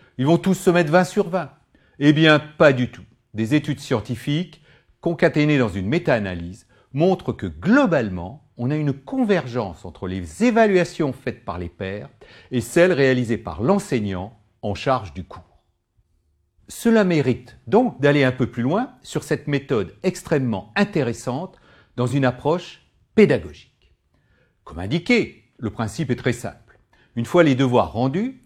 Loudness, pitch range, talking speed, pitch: -21 LUFS, 110-165 Hz, 150 wpm, 130 Hz